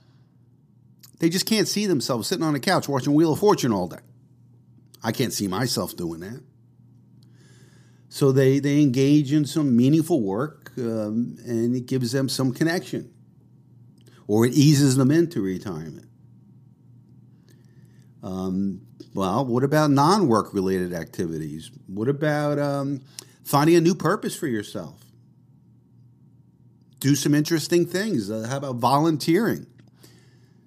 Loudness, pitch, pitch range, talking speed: -22 LUFS, 135 Hz, 120-150 Hz, 130 wpm